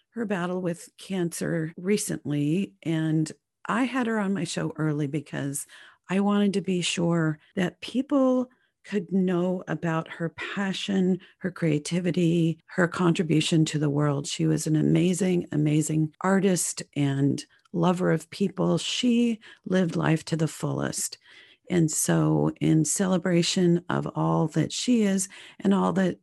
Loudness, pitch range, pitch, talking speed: -26 LUFS, 160-195 Hz, 175 Hz, 140 wpm